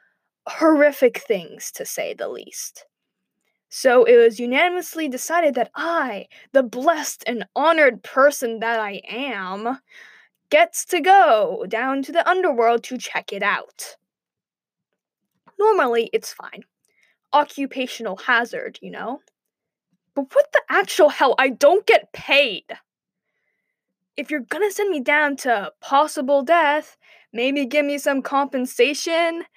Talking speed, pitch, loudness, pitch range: 125 wpm, 290 Hz, -19 LUFS, 255-335 Hz